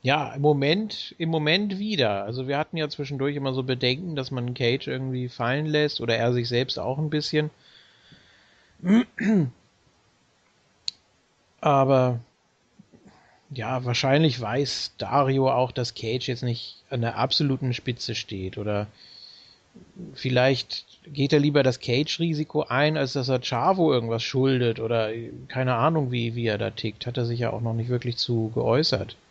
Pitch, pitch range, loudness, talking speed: 130 Hz, 120-150 Hz, -25 LUFS, 150 wpm